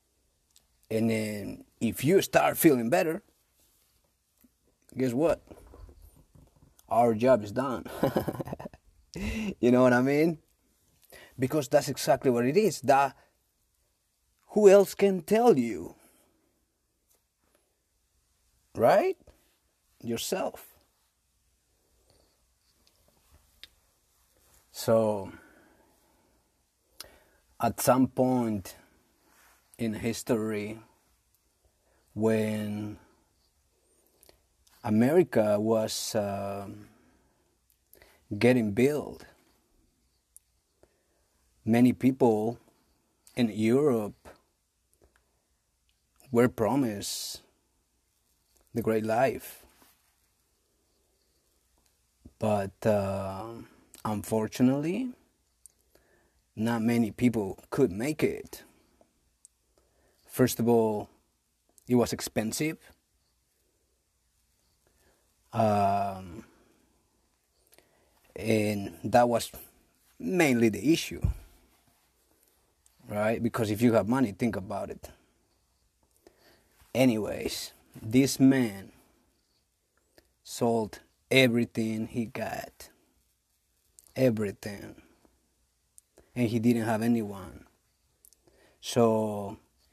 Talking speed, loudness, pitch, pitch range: 65 wpm, -27 LUFS, 110 Hz, 85-120 Hz